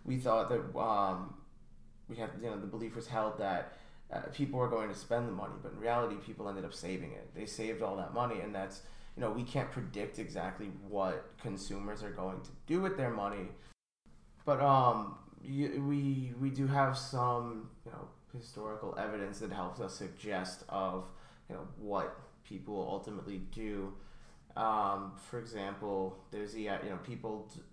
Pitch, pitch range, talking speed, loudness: 110 Hz, 100-125 Hz, 175 wpm, -38 LUFS